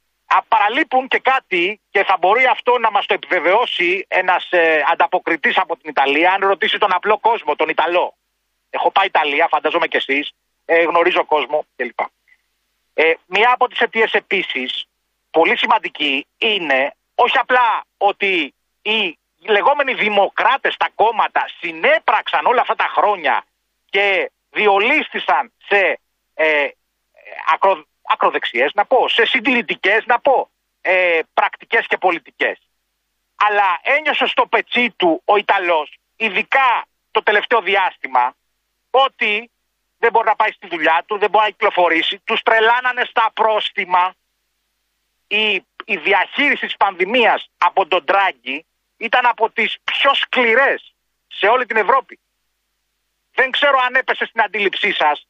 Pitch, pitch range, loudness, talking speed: 215 Hz, 185-250 Hz, -16 LUFS, 135 wpm